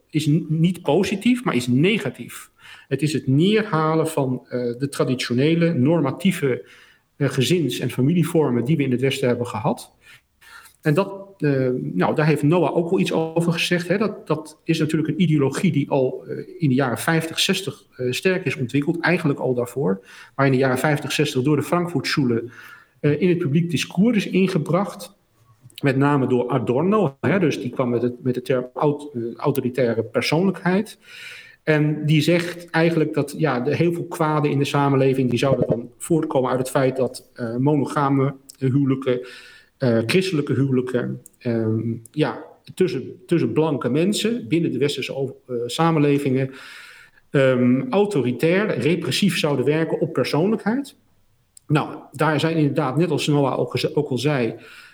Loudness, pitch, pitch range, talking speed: -21 LUFS, 145 Hz, 130-165 Hz, 160 wpm